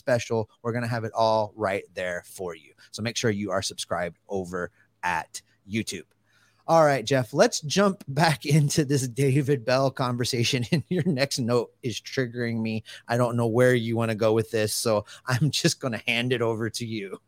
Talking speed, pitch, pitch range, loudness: 200 wpm, 120 Hz, 110-140 Hz, -25 LUFS